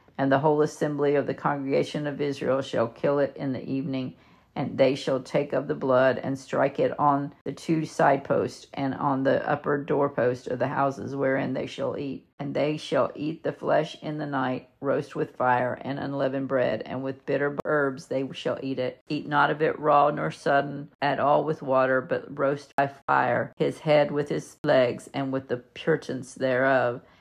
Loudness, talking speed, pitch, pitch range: -26 LUFS, 200 wpm, 135 Hz, 130-145 Hz